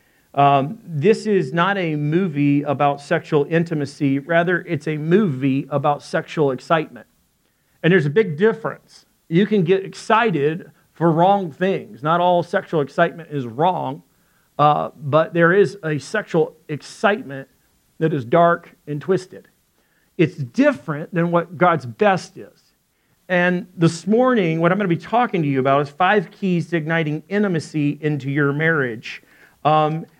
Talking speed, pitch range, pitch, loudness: 150 wpm, 145-185 Hz, 165 Hz, -19 LUFS